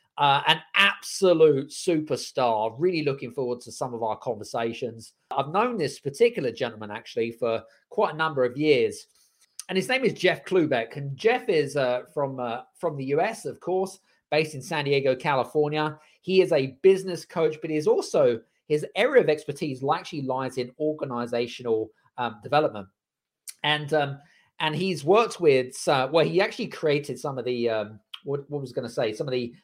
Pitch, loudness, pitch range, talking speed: 150 Hz, -25 LUFS, 125-175 Hz, 180 wpm